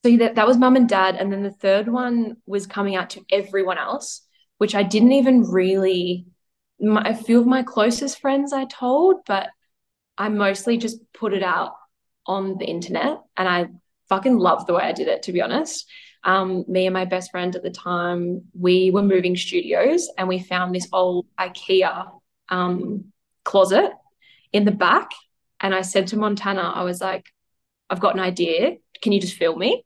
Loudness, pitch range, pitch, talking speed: -20 LUFS, 185-235 Hz, 195 Hz, 190 wpm